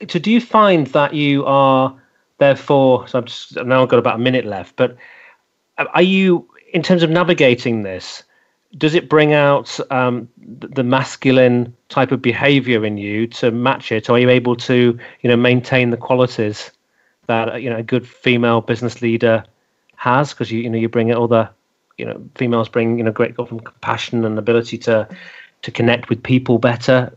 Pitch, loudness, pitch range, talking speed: 125 Hz, -16 LUFS, 115-135 Hz, 185 wpm